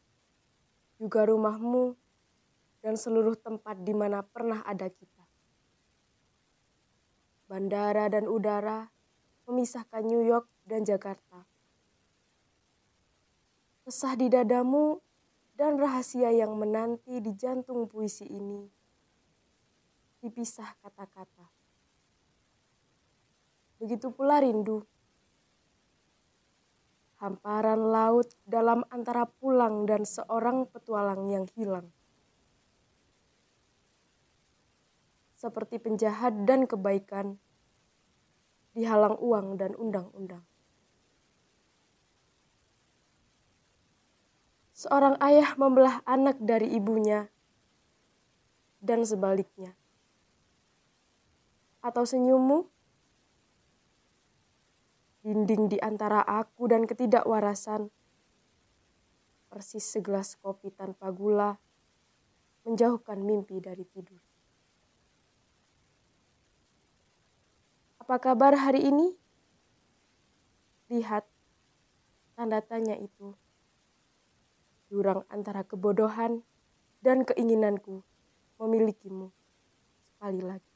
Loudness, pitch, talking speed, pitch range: -28 LUFS, 220 Hz, 70 wpm, 200-240 Hz